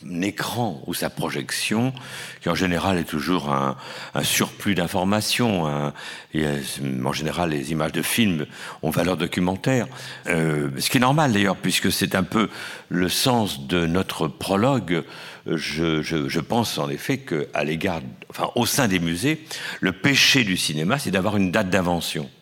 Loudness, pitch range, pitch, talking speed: -22 LUFS, 75-100 Hz, 90 Hz, 165 wpm